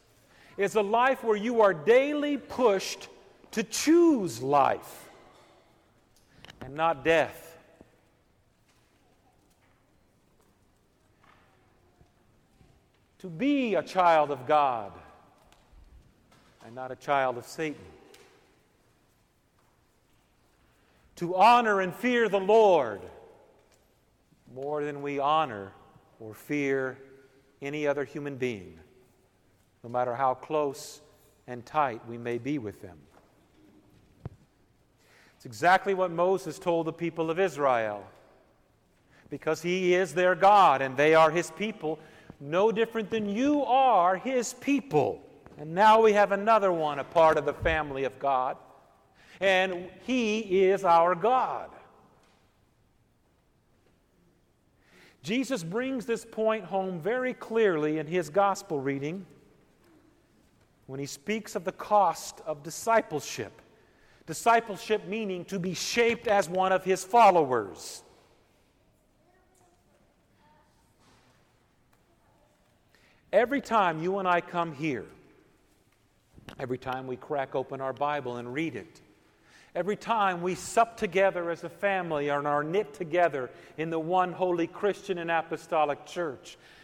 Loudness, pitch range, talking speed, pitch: -27 LUFS, 140-205 Hz, 115 wpm, 170 Hz